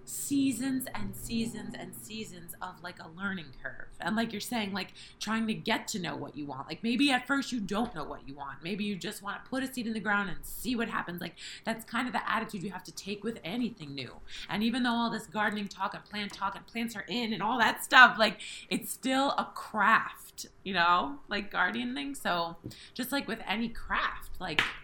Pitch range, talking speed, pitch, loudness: 180-235 Hz, 230 wpm, 210 Hz, -31 LUFS